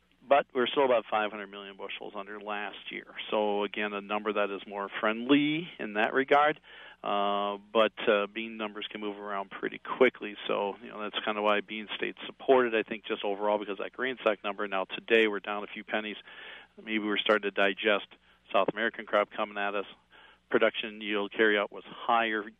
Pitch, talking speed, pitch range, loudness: 105 Hz, 195 wpm, 100-110 Hz, -30 LUFS